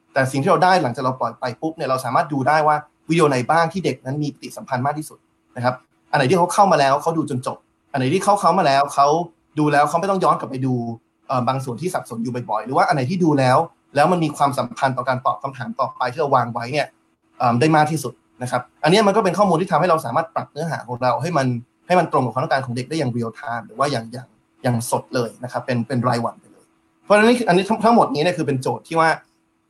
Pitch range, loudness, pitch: 125-160 Hz, -19 LUFS, 140 Hz